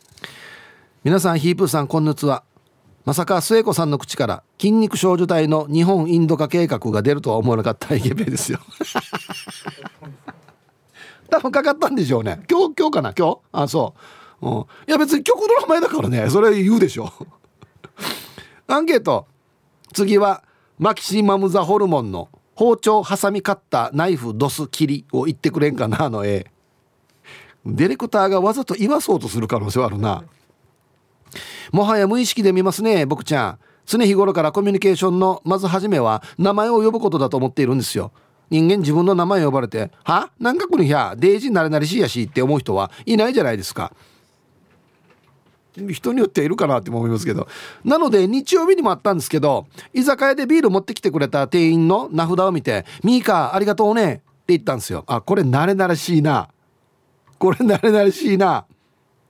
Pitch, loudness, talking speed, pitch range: 180 Hz, -18 LUFS, 370 characters per minute, 140-210 Hz